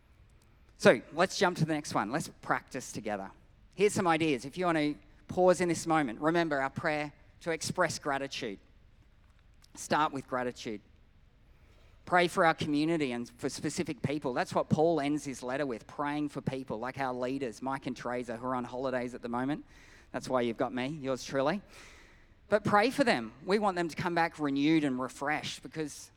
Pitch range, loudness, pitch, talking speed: 120-160 Hz, -32 LUFS, 140 Hz, 190 wpm